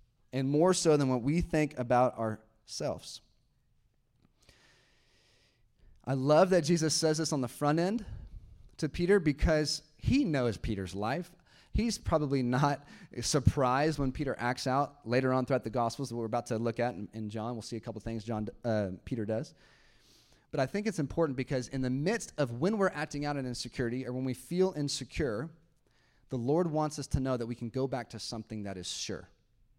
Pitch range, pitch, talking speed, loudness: 115-155 Hz, 130 Hz, 190 wpm, -32 LUFS